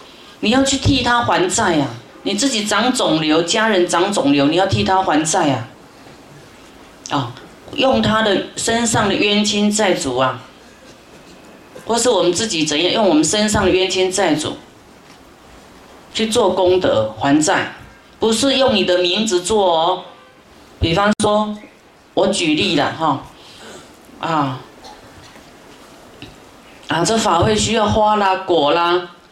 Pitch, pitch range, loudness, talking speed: 190 Hz, 175-220 Hz, -16 LUFS, 190 characters per minute